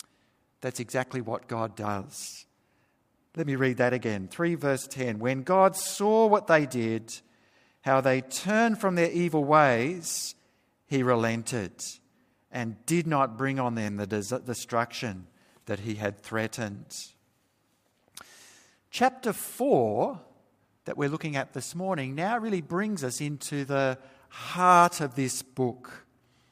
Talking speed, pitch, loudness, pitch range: 130 wpm, 130 Hz, -28 LUFS, 120-165 Hz